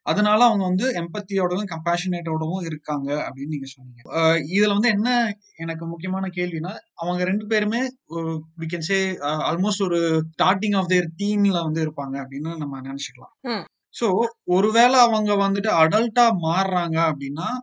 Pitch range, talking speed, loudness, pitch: 160-210 Hz, 125 wpm, -22 LUFS, 180 Hz